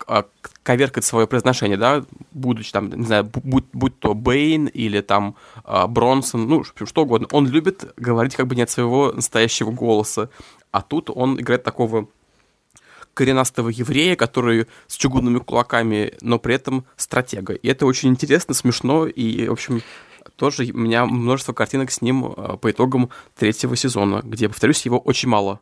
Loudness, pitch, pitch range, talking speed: -19 LUFS, 125 Hz, 115-130 Hz, 160 wpm